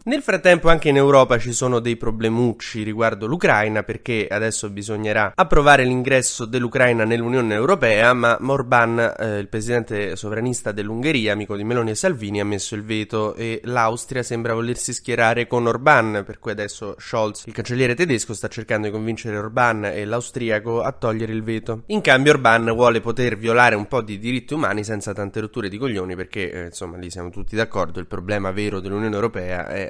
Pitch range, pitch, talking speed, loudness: 105-120 Hz, 115 Hz, 180 wpm, -20 LUFS